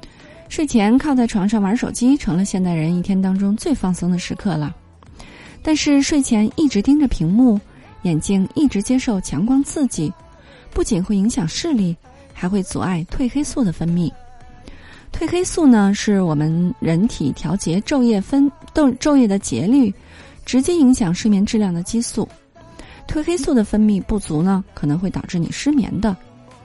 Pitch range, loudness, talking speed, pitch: 180-260 Hz, -18 LUFS, 250 characters per minute, 210 Hz